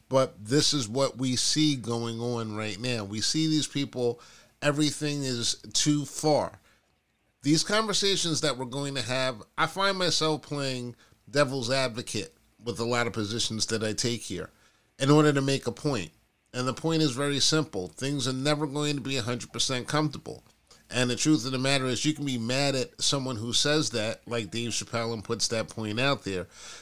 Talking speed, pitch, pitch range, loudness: 190 wpm, 130 Hz, 115-145 Hz, -27 LUFS